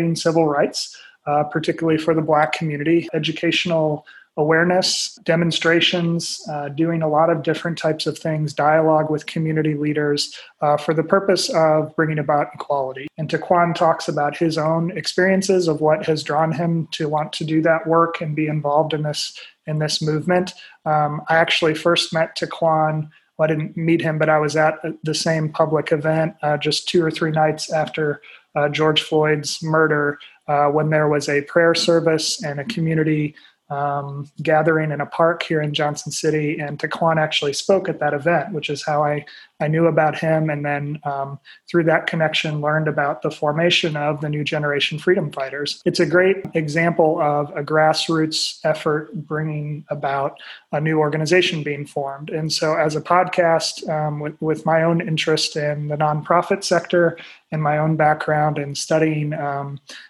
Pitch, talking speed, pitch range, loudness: 155 Hz, 175 wpm, 150-165 Hz, -20 LUFS